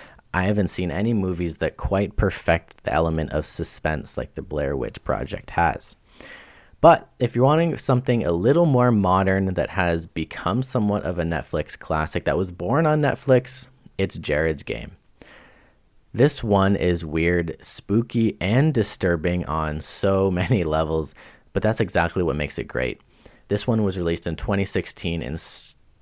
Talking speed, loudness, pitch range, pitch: 155 wpm, -23 LUFS, 85-115 Hz, 95 Hz